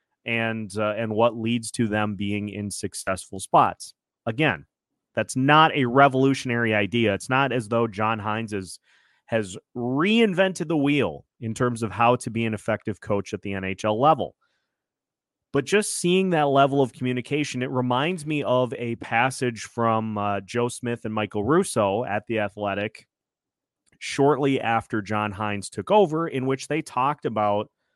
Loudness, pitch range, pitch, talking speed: -24 LUFS, 105-135 Hz, 115 Hz, 160 wpm